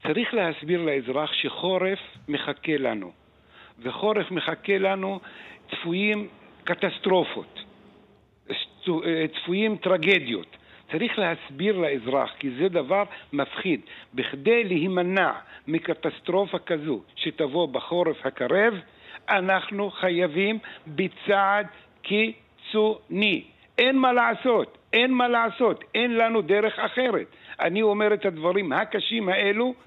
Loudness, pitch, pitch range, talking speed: -25 LUFS, 195 Hz, 170-215 Hz, 90 wpm